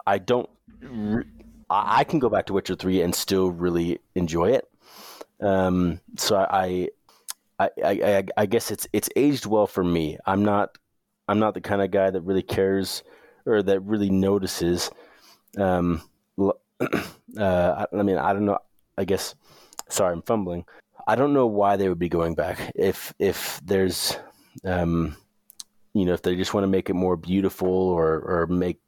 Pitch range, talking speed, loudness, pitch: 90-100 Hz, 170 wpm, -24 LUFS, 95 Hz